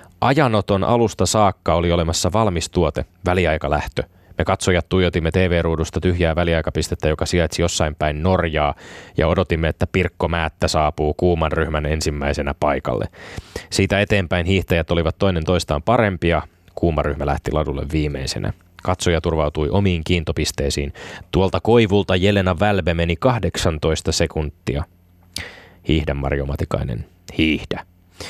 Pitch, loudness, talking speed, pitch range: 85 Hz, -20 LUFS, 115 wpm, 80-95 Hz